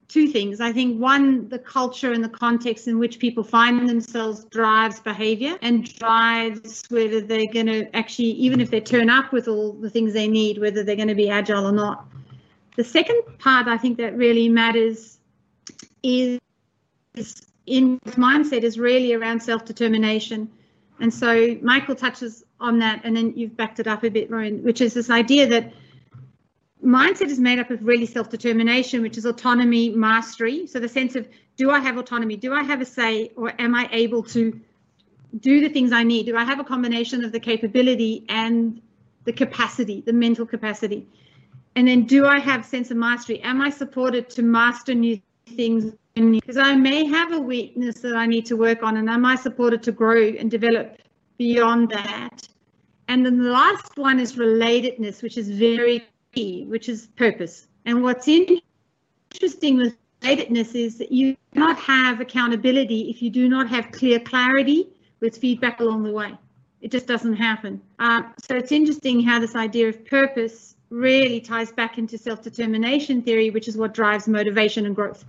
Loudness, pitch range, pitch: -20 LUFS, 225-250 Hz, 235 Hz